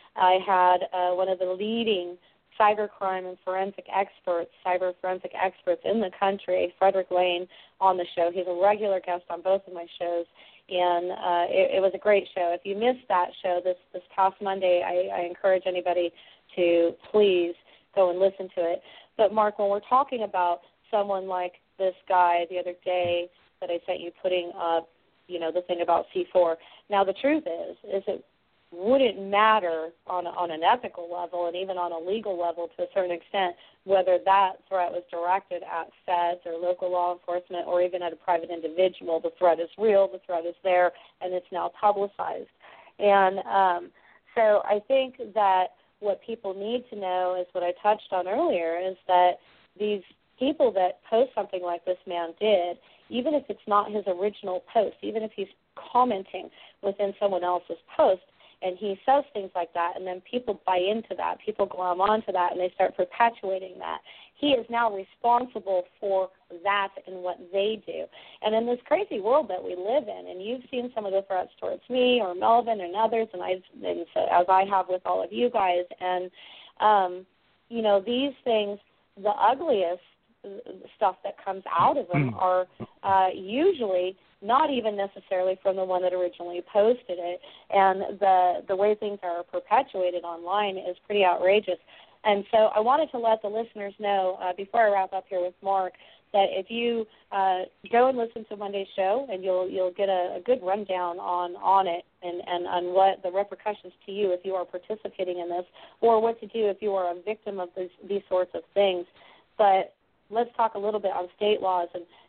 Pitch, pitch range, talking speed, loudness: 190 Hz, 180-205 Hz, 190 wpm, -26 LUFS